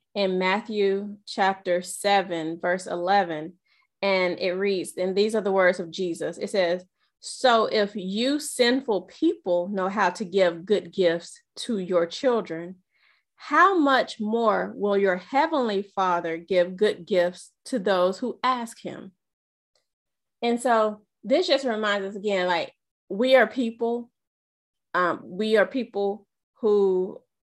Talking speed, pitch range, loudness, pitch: 135 wpm, 185-230 Hz, -24 LUFS, 200 Hz